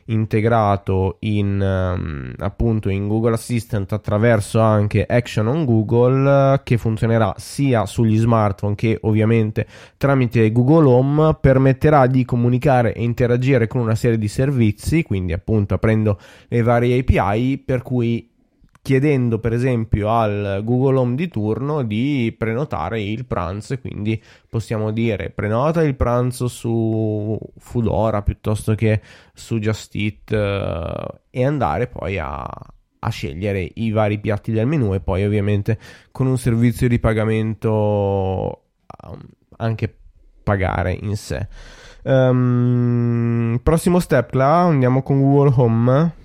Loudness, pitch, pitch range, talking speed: -19 LUFS, 115 Hz, 105-125 Hz, 125 wpm